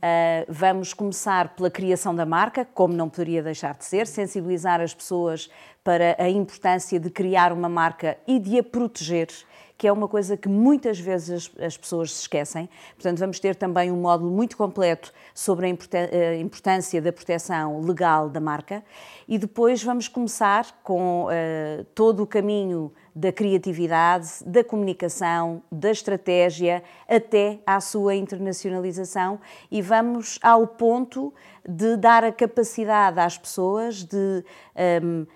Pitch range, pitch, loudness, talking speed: 170-210 Hz, 185 Hz, -23 LUFS, 145 wpm